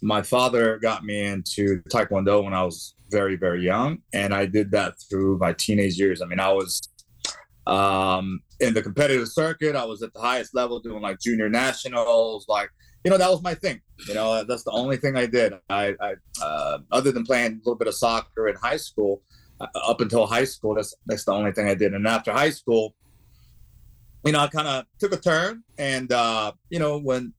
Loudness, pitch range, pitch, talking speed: -24 LUFS, 100-130 Hz, 110 Hz, 215 wpm